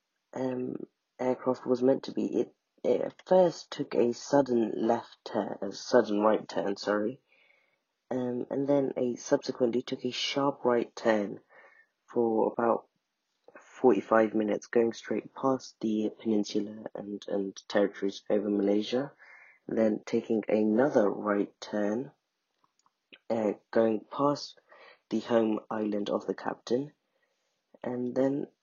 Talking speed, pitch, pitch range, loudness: 125 wpm, 115 Hz, 105-130 Hz, -30 LUFS